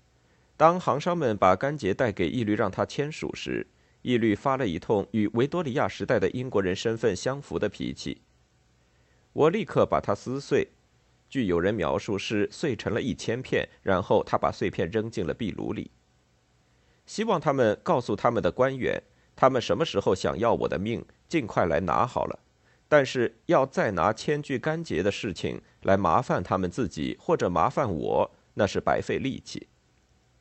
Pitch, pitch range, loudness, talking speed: 110 Hz, 90-135 Hz, -27 LUFS, 255 characters per minute